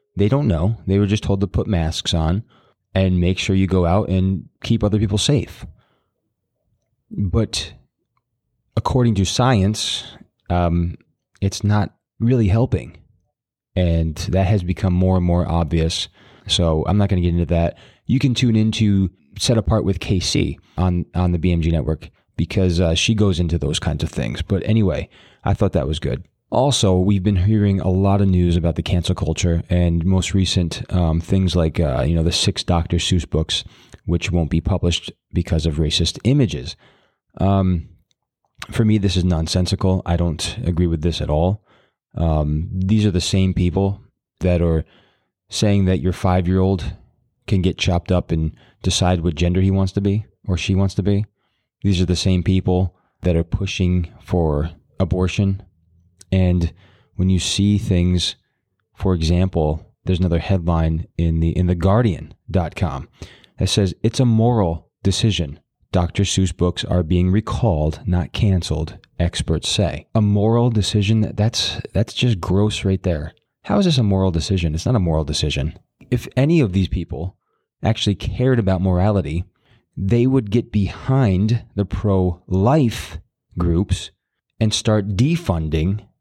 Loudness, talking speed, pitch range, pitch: -19 LUFS, 160 wpm, 85-105 Hz, 95 Hz